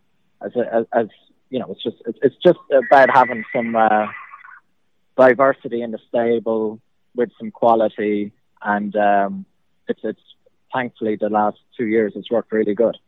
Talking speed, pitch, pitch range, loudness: 150 wpm, 110 Hz, 105-120 Hz, -19 LUFS